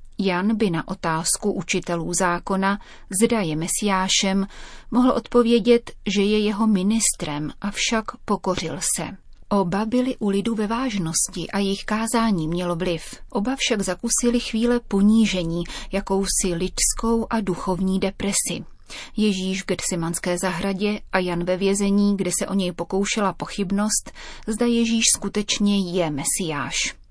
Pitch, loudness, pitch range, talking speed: 200 Hz, -22 LUFS, 185-220 Hz, 130 wpm